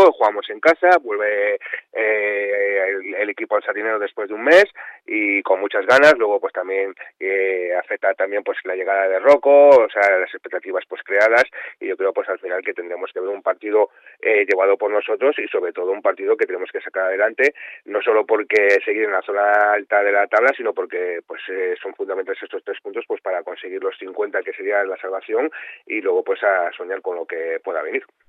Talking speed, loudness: 210 wpm, -19 LUFS